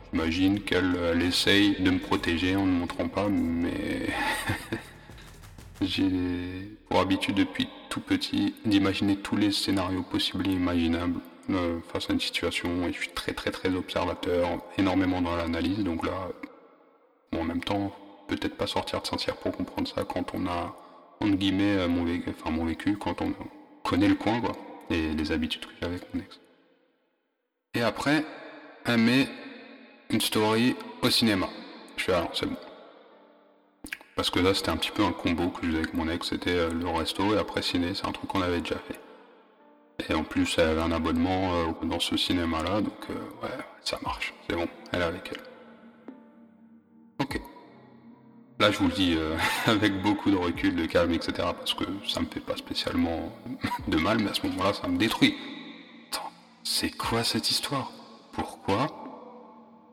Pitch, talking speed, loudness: 125 Hz, 180 wpm, -28 LUFS